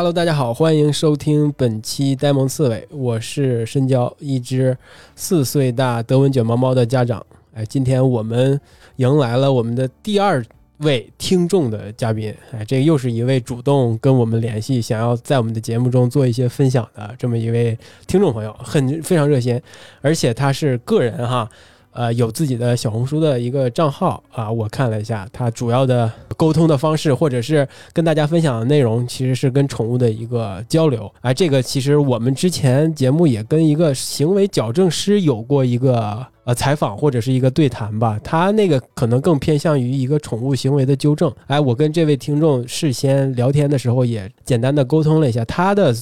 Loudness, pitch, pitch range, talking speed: -17 LUFS, 130 Hz, 120-150 Hz, 305 characters per minute